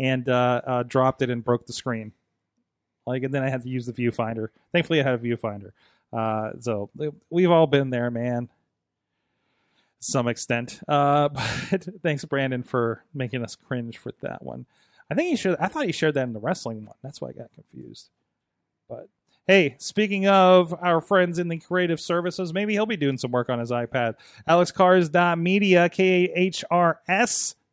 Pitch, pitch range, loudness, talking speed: 140 Hz, 120-175 Hz, -23 LUFS, 185 wpm